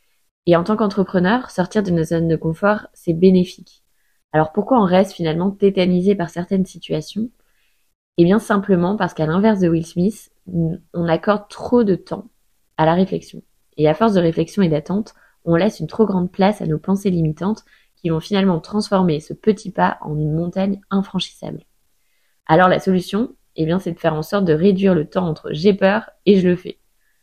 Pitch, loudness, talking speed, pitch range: 185 Hz, -18 LUFS, 190 wpm, 165-200 Hz